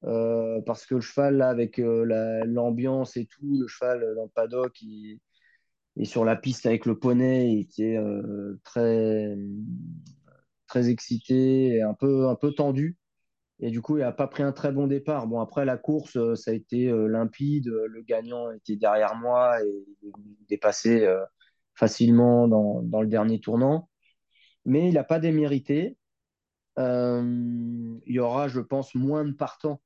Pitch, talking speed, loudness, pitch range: 120 Hz, 170 wpm, -25 LUFS, 110-135 Hz